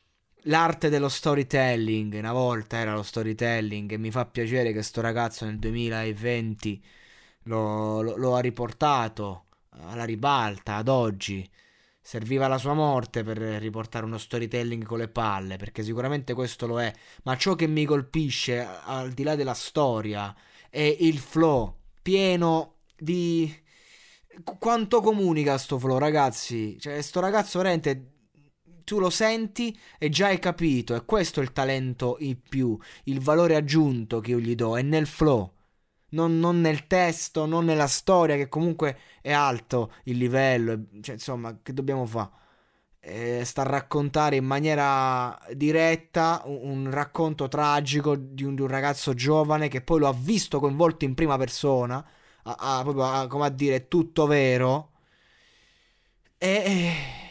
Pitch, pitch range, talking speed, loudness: 135 Hz, 115-155 Hz, 150 wpm, -26 LUFS